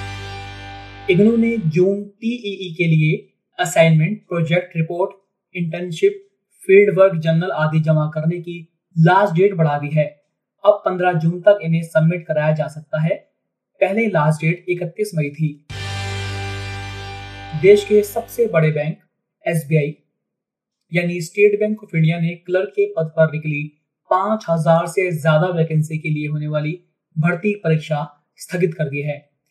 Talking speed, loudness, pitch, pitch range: 140 wpm, -18 LUFS, 165 Hz, 155-190 Hz